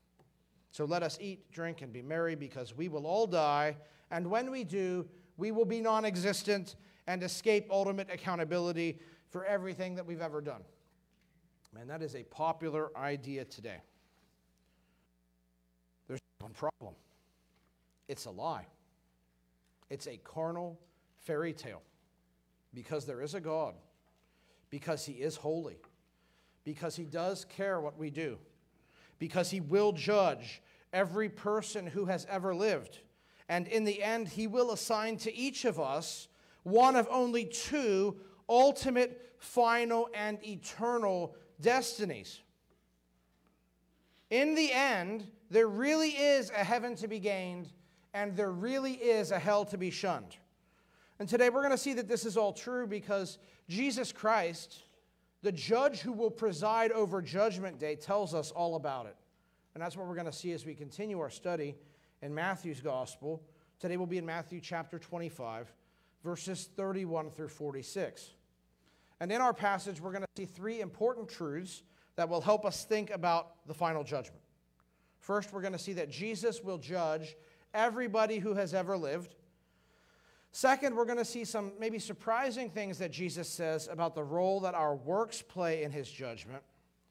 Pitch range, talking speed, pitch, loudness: 155-210 Hz, 155 wpm, 180 Hz, -35 LUFS